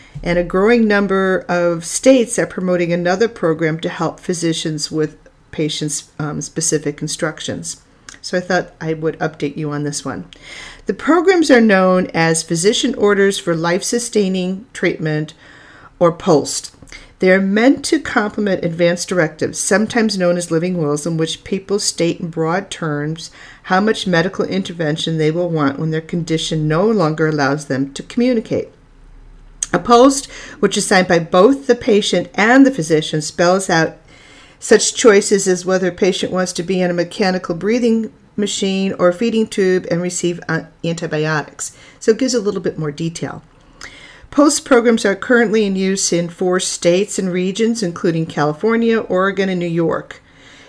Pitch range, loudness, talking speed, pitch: 160-205 Hz, -16 LUFS, 160 wpm, 180 Hz